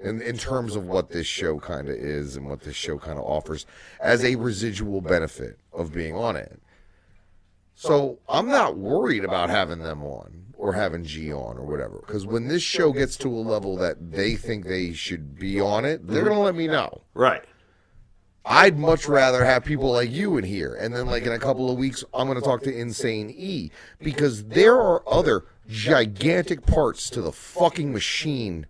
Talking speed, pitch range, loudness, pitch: 200 wpm, 90-135 Hz, -23 LUFS, 115 Hz